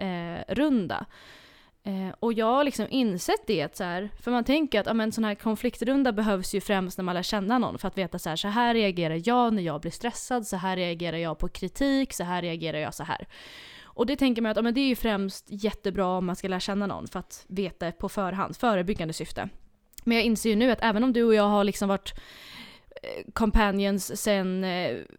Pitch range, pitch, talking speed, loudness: 185-235 Hz, 205 Hz, 220 wpm, -27 LUFS